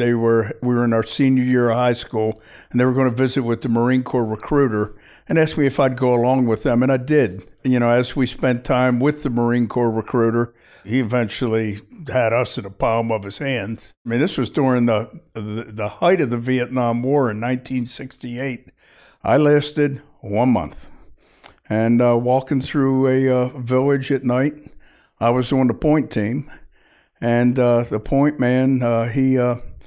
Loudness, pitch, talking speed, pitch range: -19 LUFS, 125 Hz, 195 wpm, 115-135 Hz